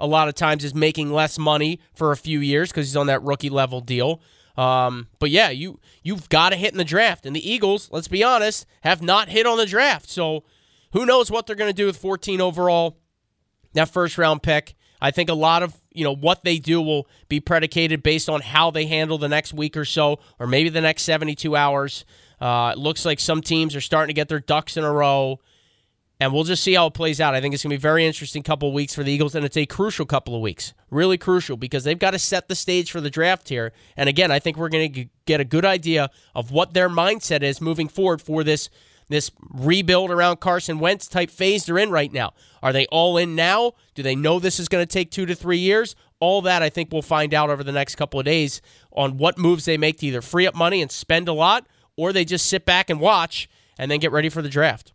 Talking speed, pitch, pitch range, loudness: 255 wpm, 155 Hz, 145-175 Hz, -20 LUFS